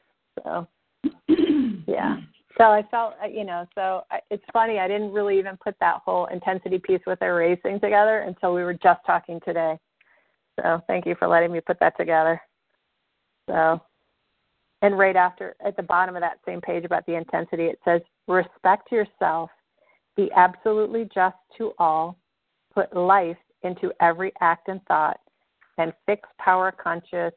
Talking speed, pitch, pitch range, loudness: 155 wpm, 185 Hz, 170-205 Hz, -23 LUFS